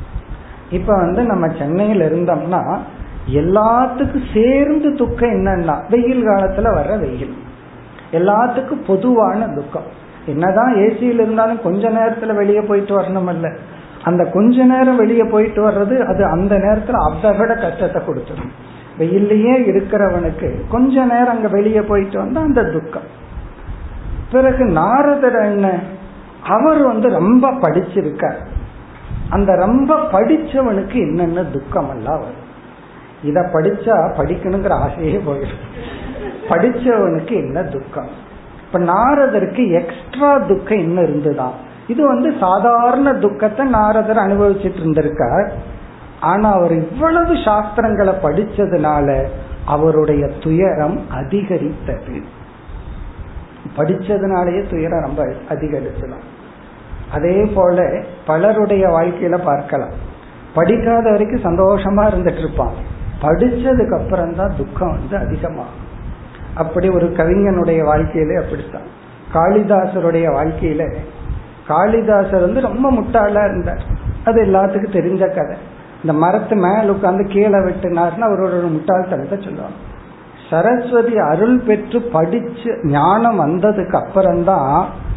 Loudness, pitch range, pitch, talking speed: -15 LUFS, 165-225 Hz, 195 Hz, 100 wpm